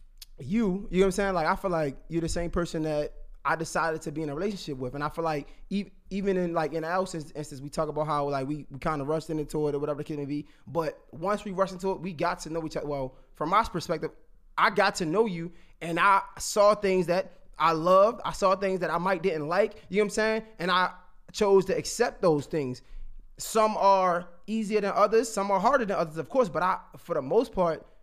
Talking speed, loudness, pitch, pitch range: 255 wpm, -28 LUFS, 175 Hz, 155-195 Hz